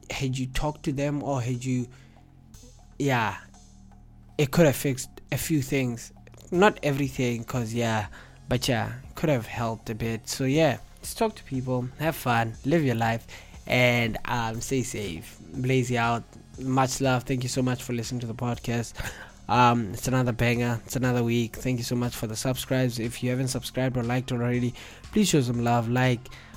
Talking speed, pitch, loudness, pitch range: 185 wpm, 125 Hz, -27 LUFS, 115-130 Hz